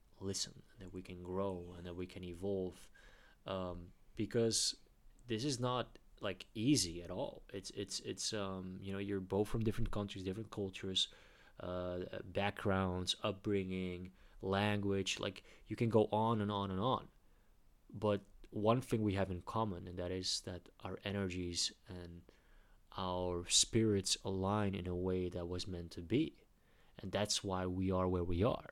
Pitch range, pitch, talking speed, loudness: 90-105 Hz, 95 Hz, 165 wpm, -39 LUFS